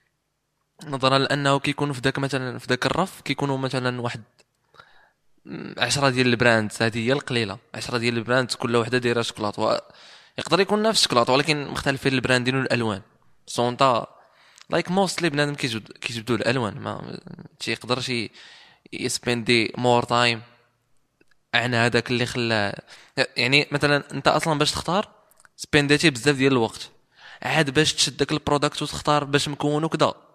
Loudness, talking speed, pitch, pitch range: -22 LUFS, 135 wpm, 130 Hz, 120-145 Hz